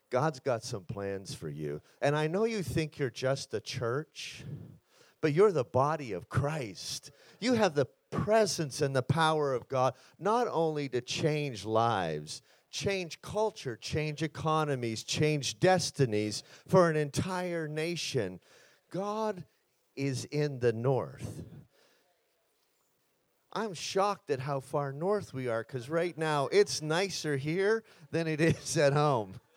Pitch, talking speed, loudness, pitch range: 150 Hz, 140 wpm, -31 LUFS, 130-170 Hz